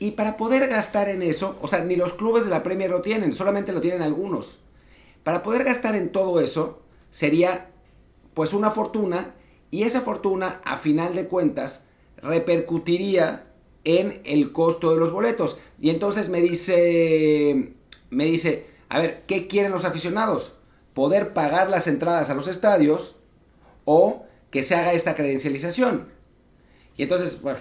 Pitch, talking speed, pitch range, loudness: 175 Hz, 155 wpm, 160-200 Hz, -23 LUFS